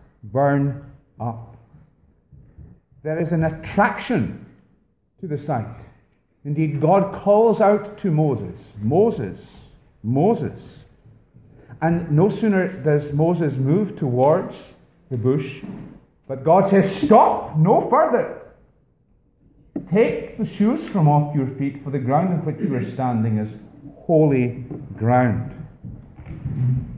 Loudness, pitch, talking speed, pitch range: -20 LUFS, 145 Hz, 110 wpm, 130-185 Hz